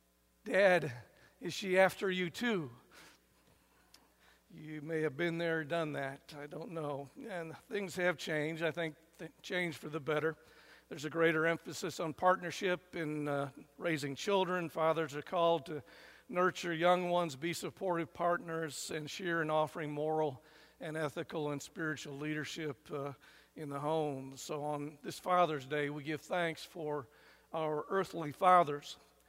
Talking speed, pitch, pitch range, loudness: 150 wpm, 160 Hz, 150-175 Hz, -36 LUFS